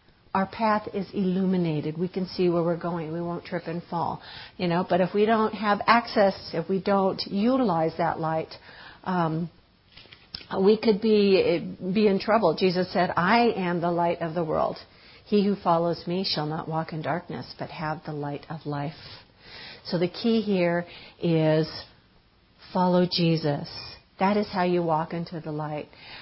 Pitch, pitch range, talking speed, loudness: 175 Hz, 165-195 Hz, 170 wpm, -25 LUFS